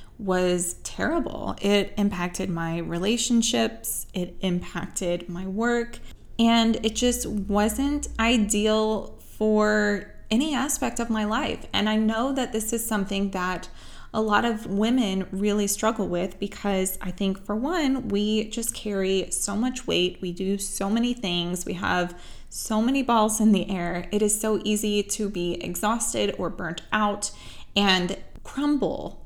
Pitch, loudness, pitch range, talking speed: 210 Hz, -25 LUFS, 185-225 Hz, 150 wpm